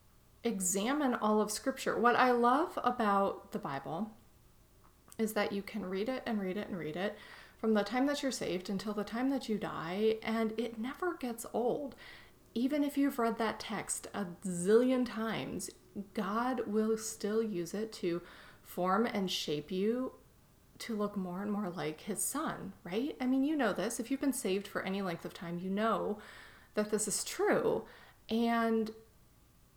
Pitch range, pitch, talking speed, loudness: 195-240 Hz, 215 Hz, 175 wpm, -34 LUFS